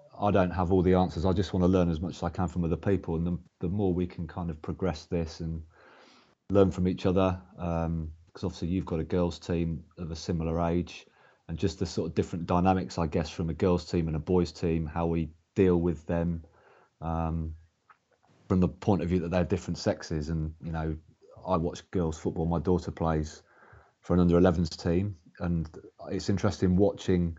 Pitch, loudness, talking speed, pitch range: 85 Hz, -29 LUFS, 215 wpm, 80-95 Hz